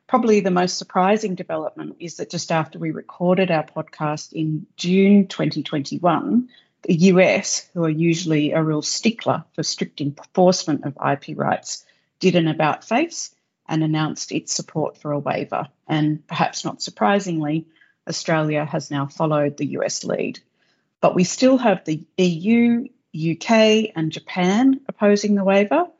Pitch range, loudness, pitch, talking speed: 155-200 Hz, -20 LUFS, 175 Hz, 150 wpm